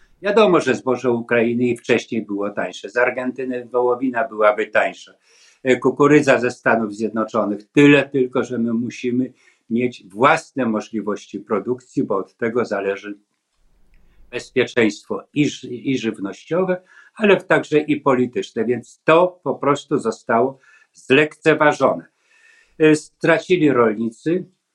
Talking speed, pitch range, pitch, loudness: 115 wpm, 115-150 Hz, 125 Hz, -19 LUFS